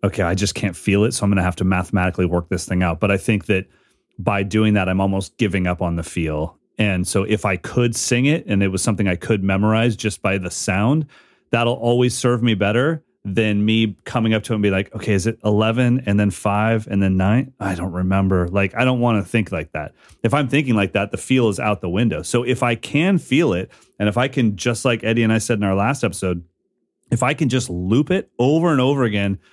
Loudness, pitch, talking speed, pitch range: -19 LUFS, 105 Hz, 250 wpm, 95-120 Hz